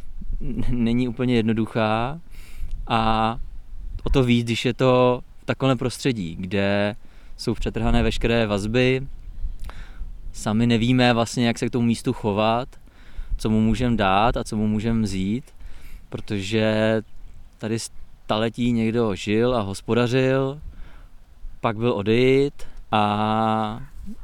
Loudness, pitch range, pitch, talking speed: -22 LUFS, 100-120 Hz, 115 Hz, 115 wpm